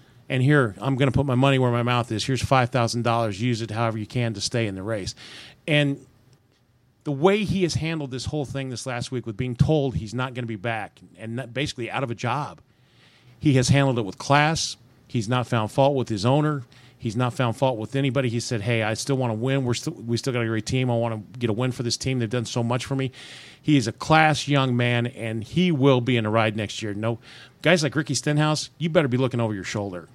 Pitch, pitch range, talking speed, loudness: 125 Hz, 115-135 Hz, 260 wpm, -24 LUFS